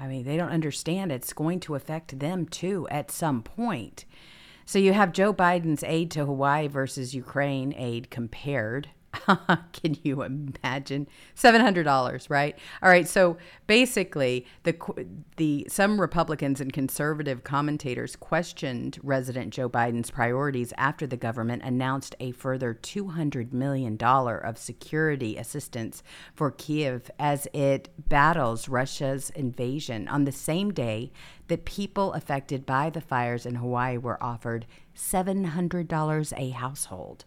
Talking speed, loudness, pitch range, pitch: 140 wpm, -27 LUFS, 125-165 Hz, 140 Hz